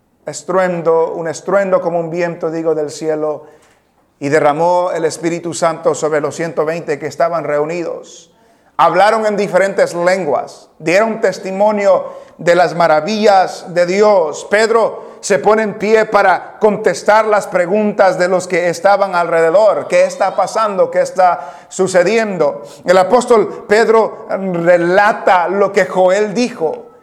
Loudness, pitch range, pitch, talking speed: -13 LUFS, 170-210 Hz, 185 Hz, 130 wpm